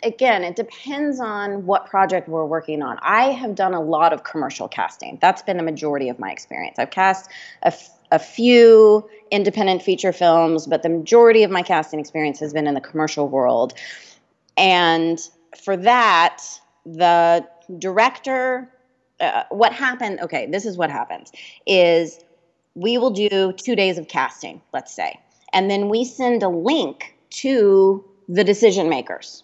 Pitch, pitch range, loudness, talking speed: 190 Hz, 170-230 Hz, -18 LUFS, 160 wpm